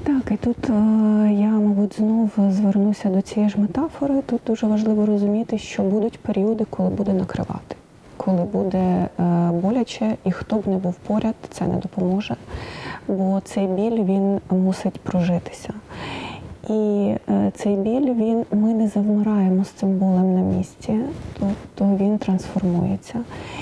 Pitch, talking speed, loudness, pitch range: 205 Hz, 135 wpm, -21 LUFS, 190-220 Hz